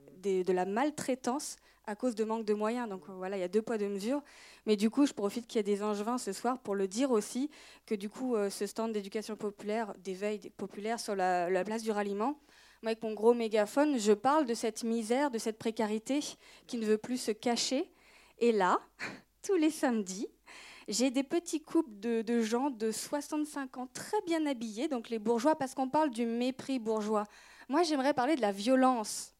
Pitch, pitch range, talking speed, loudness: 230 Hz, 210-275 Hz, 210 wpm, -33 LUFS